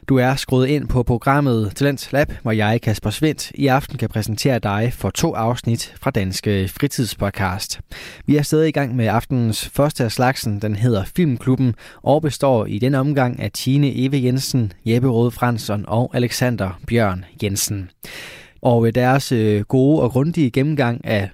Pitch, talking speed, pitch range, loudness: 125 Hz, 170 wpm, 110-135 Hz, -19 LUFS